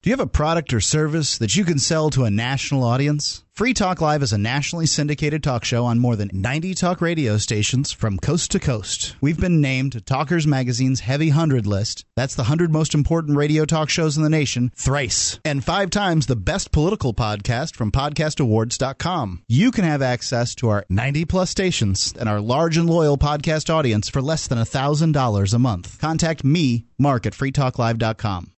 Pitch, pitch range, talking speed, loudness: 135 Hz, 120-155 Hz, 190 wpm, -20 LUFS